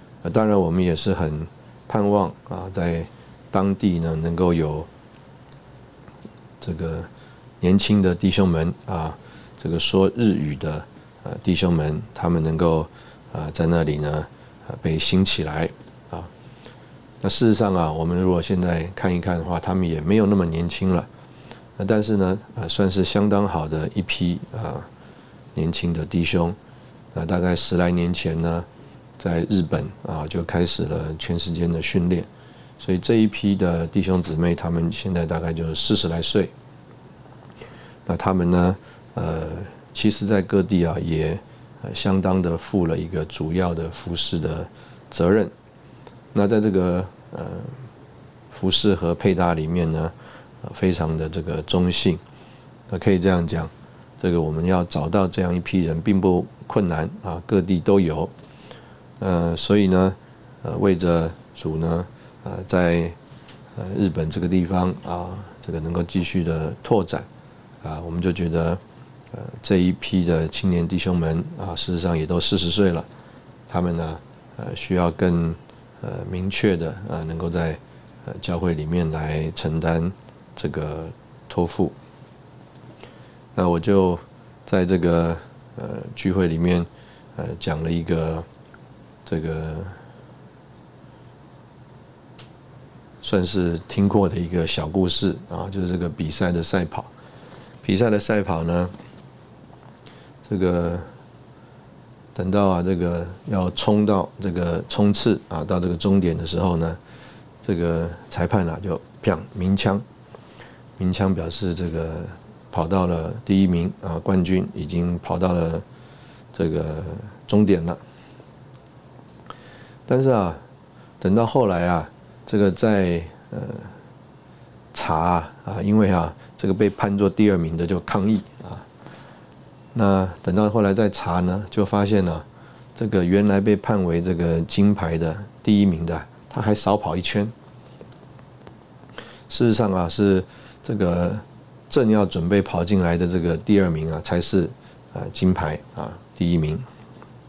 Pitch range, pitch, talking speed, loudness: 85-100 Hz, 90 Hz, 200 characters per minute, -22 LUFS